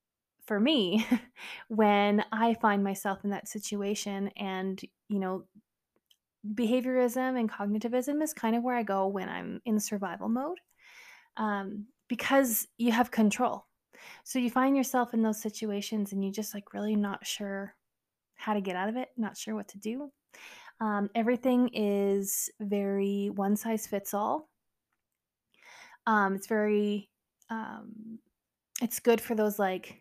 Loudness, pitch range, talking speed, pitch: -30 LUFS, 200-245 Hz, 145 wpm, 215 Hz